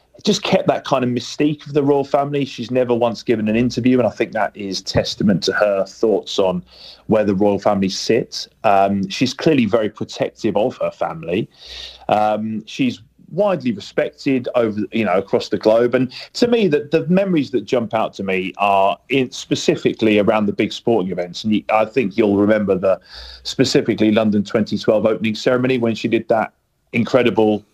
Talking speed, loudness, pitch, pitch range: 185 wpm, -18 LUFS, 110 Hz, 105-135 Hz